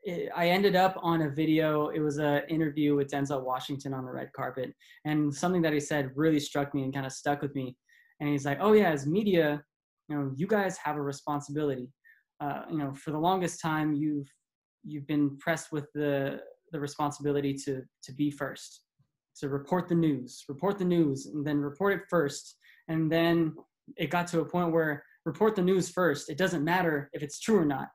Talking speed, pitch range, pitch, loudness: 205 wpm, 145-170 Hz, 150 Hz, -30 LUFS